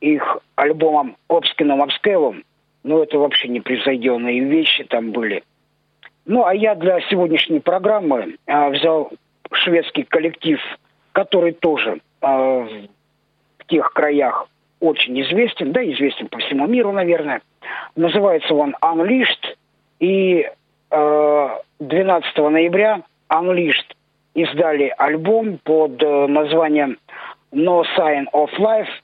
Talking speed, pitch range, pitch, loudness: 105 wpm, 145-185 Hz, 160 Hz, -17 LUFS